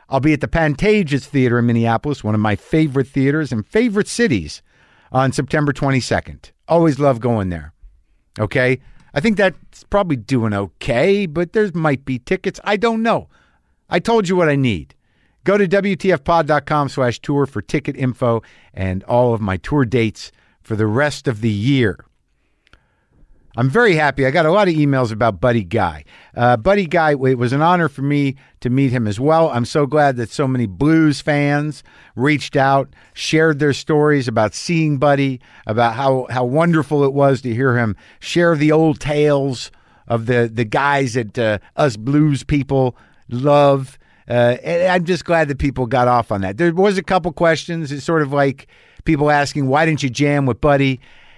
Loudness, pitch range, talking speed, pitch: -17 LUFS, 120-155 Hz, 180 wpm, 140 Hz